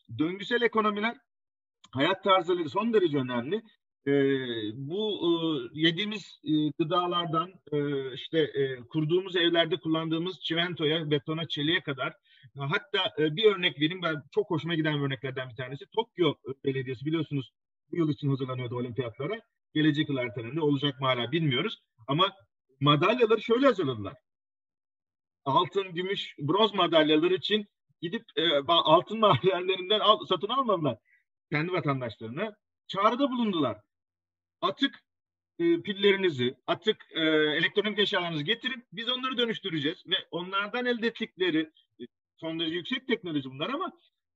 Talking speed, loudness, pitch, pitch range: 125 wpm, -28 LUFS, 165 Hz, 140-205 Hz